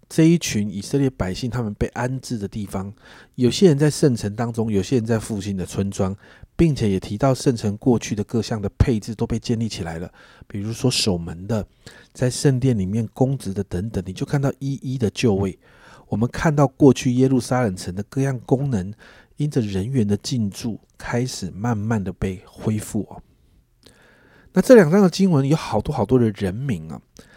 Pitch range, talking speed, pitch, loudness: 100-130 Hz, 285 characters per minute, 115 Hz, -21 LUFS